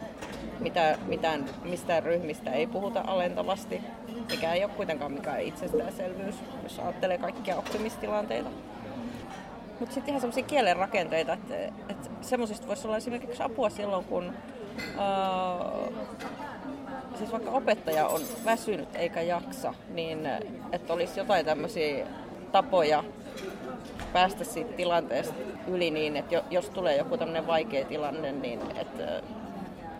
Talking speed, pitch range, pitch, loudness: 120 wpm, 175-240 Hz, 210 Hz, -31 LUFS